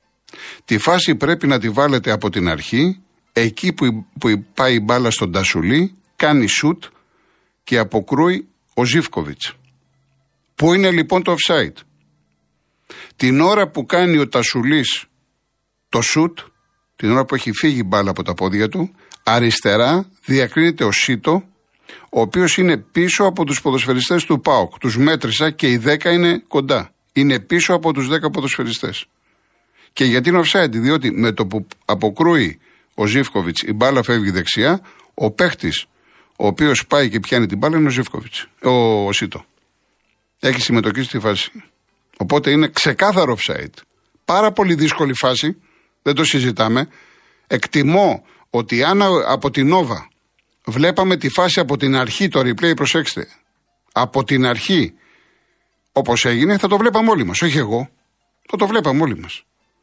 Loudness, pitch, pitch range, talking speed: -16 LUFS, 135 Hz, 115-165 Hz, 150 wpm